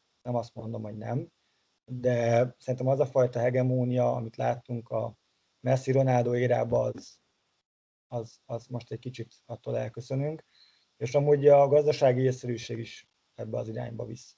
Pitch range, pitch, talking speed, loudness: 115-130 Hz, 125 Hz, 145 wpm, -28 LUFS